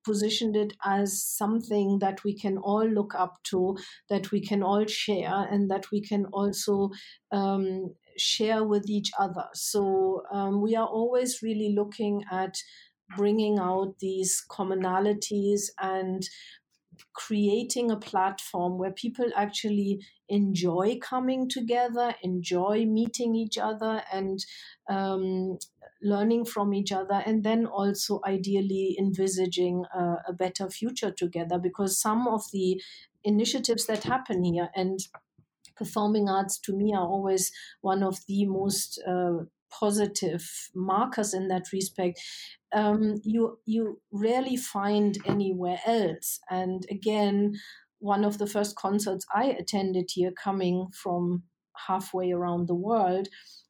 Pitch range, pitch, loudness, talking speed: 190-215 Hz, 200 Hz, -28 LUFS, 130 wpm